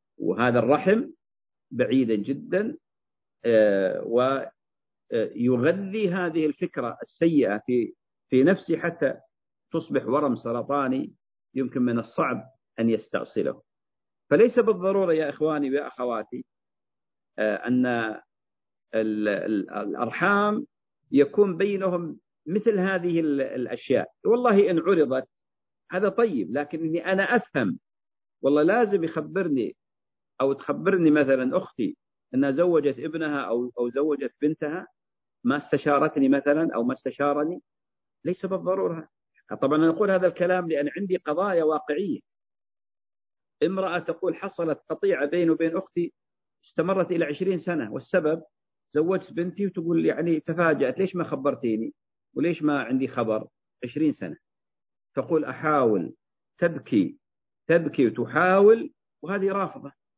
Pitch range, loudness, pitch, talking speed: 135-185 Hz, -25 LUFS, 160 Hz, 105 wpm